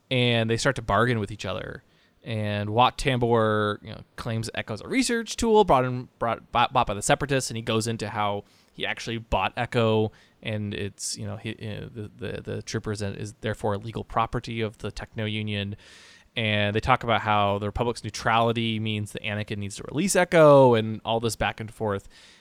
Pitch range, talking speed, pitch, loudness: 105-120 Hz, 205 wpm, 110 Hz, -25 LUFS